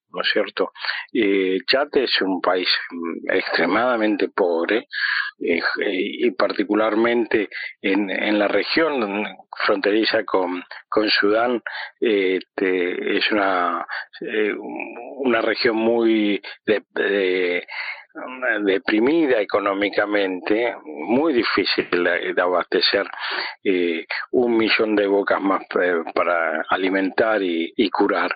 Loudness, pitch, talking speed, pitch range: -20 LUFS, 100 Hz, 100 wpm, 95-115 Hz